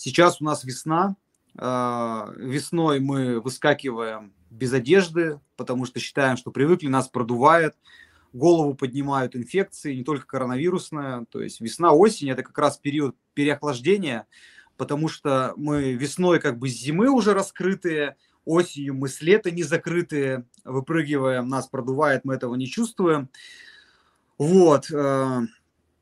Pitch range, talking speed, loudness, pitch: 130-165 Hz, 125 wpm, -23 LUFS, 140 Hz